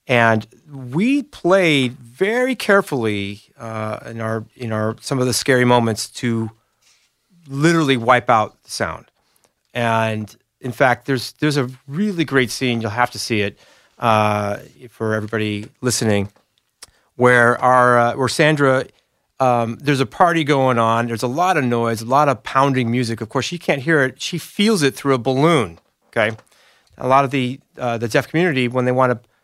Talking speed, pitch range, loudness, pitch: 175 wpm, 115-140 Hz, -18 LUFS, 125 Hz